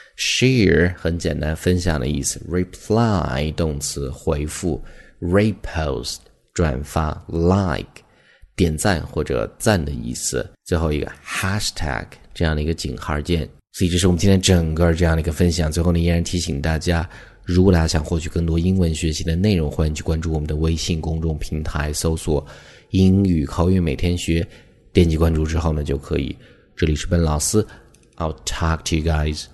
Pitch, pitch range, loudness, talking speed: 80 Hz, 75-90 Hz, -20 LUFS, 320 characters per minute